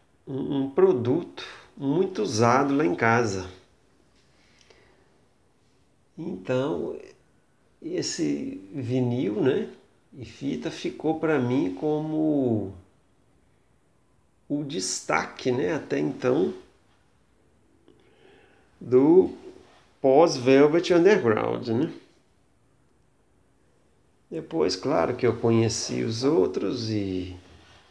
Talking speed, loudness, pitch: 75 wpm, -24 LUFS, 140 Hz